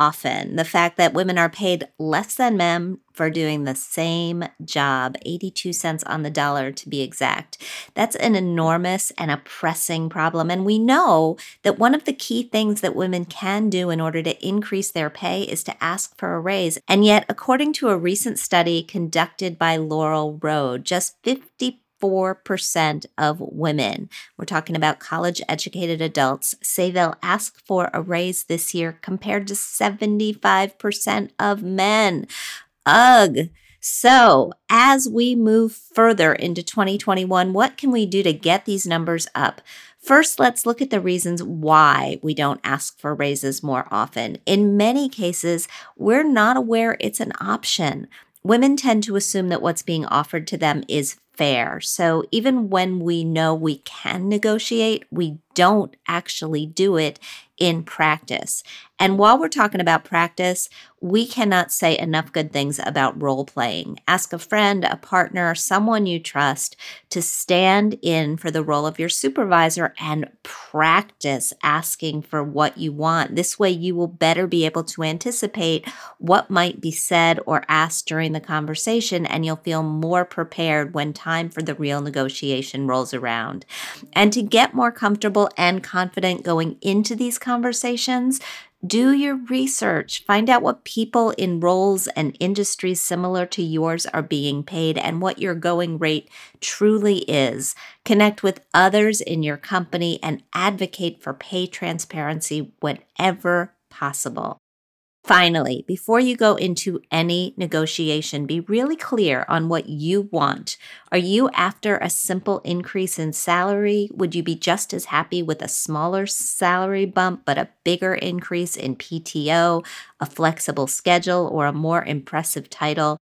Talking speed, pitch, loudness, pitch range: 155 wpm, 175 Hz, -20 LUFS, 160-200 Hz